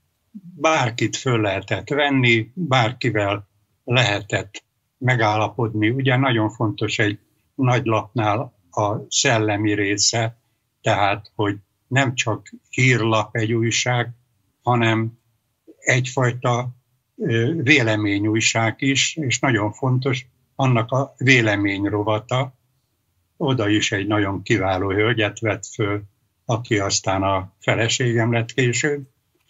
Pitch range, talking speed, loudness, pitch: 105-125 Hz, 100 wpm, -20 LUFS, 115 Hz